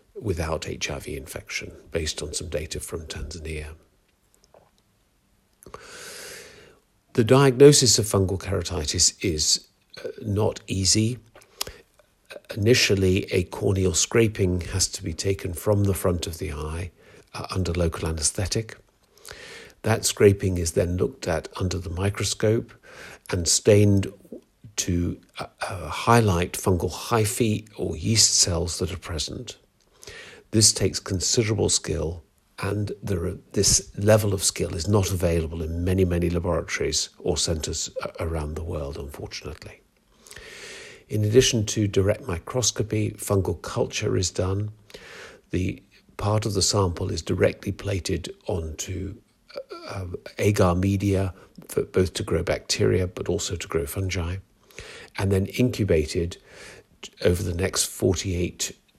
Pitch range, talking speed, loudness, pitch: 90-105 Hz, 125 wpm, -24 LUFS, 95 Hz